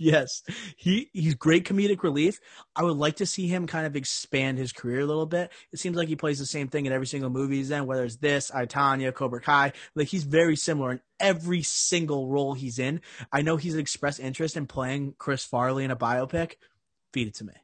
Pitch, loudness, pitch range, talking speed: 145 Hz, -27 LUFS, 130-165 Hz, 225 wpm